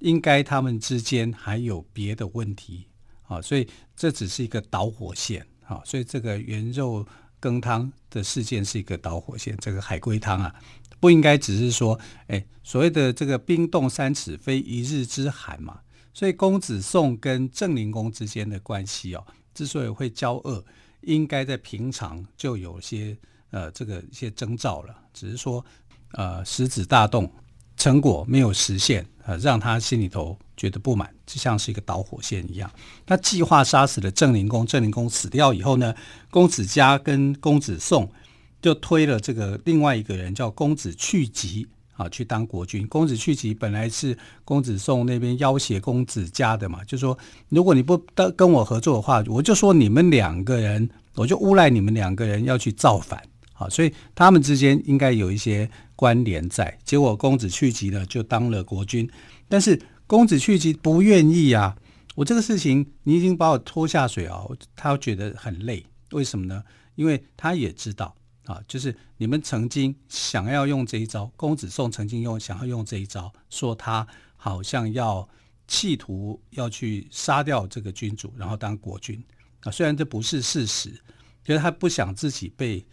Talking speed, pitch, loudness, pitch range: 265 characters per minute, 115 Hz, -22 LUFS, 105-135 Hz